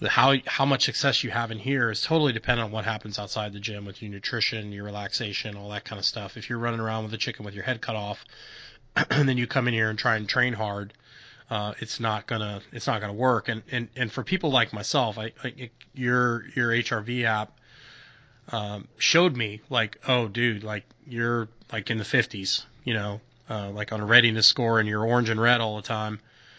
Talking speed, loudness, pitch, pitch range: 225 wpm, -26 LUFS, 115 Hz, 105-125 Hz